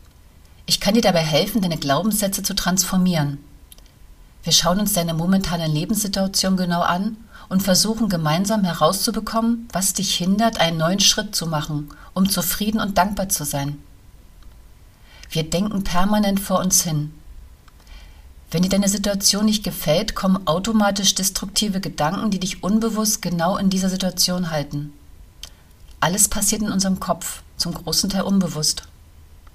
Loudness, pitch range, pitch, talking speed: -20 LUFS, 150-200 Hz, 180 Hz, 140 wpm